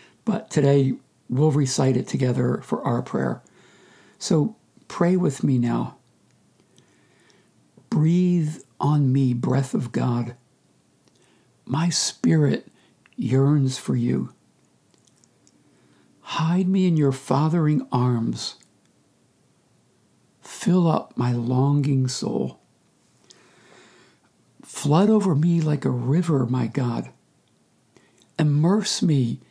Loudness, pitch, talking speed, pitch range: -22 LUFS, 140 Hz, 95 wpm, 125-160 Hz